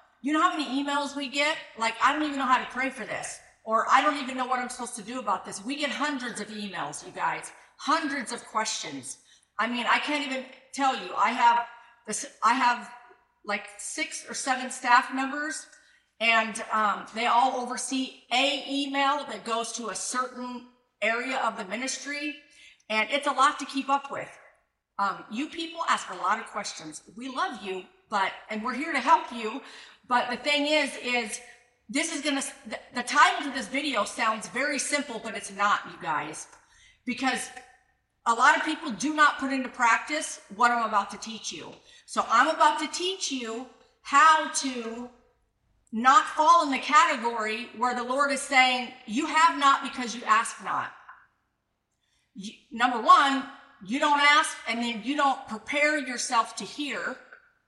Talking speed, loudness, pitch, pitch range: 185 wpm, -26 LUFS, 255 Hz, 225-290 Hz